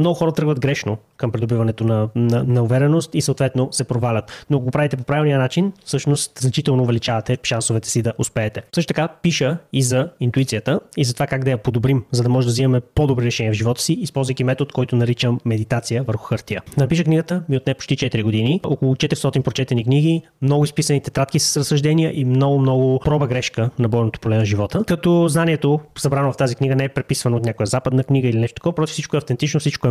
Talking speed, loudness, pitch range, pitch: 215 wpm, -19 LUFS, 120-150 Hz, 135 Hz